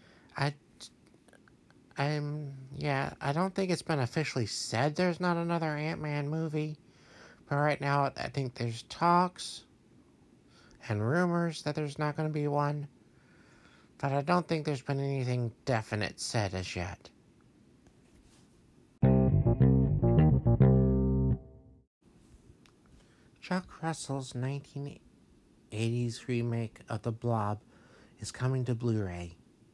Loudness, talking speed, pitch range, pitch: -31 LUFS, 105 wpm, 115-150 Hz, 135 Hz